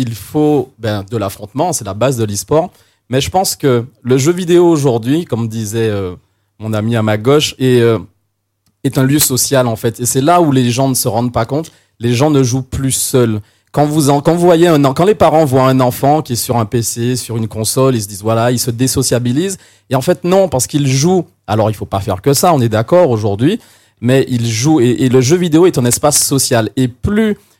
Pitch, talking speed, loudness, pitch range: 125 Hz, 230 wpm, -13 LUFS, 115-145 Hz